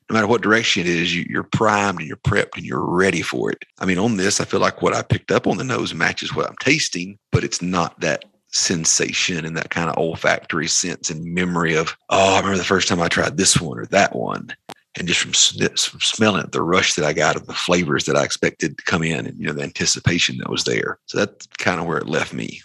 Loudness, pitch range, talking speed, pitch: -19 LUFS, 85-95 Hz, 260 wpm, 90 Hz